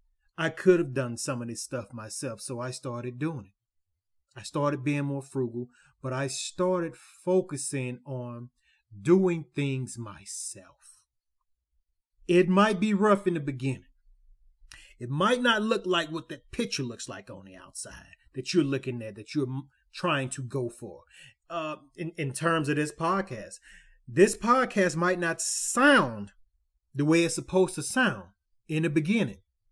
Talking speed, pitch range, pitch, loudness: 160 wpm, 120-170 Hz, 140 Hz, -28 LUFS